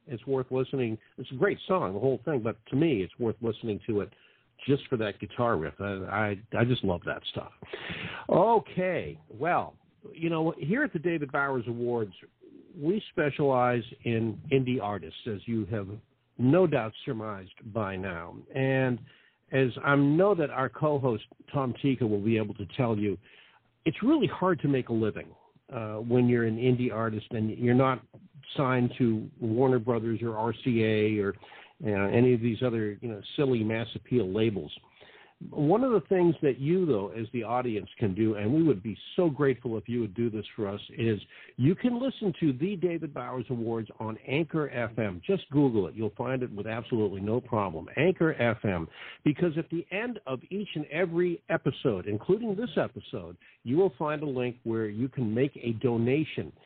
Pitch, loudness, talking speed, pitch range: 125 Hz, -29 LUFS, 185 wpm, 110-145 Hz